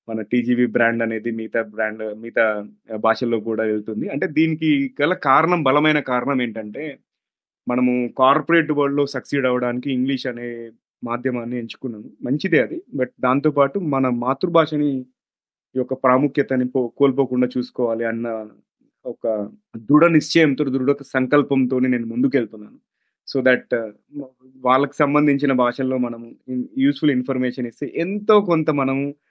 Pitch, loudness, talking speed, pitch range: 130 Hz, -20 LUFS, 120 wpm, 120-140 Hz